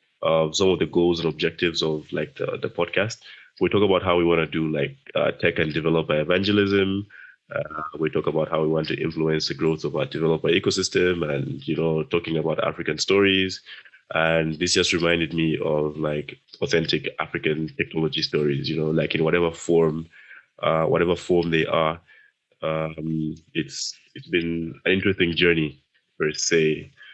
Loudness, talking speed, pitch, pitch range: -23 LUFS, 175 wpm, 80 Hz, 80-85 Hz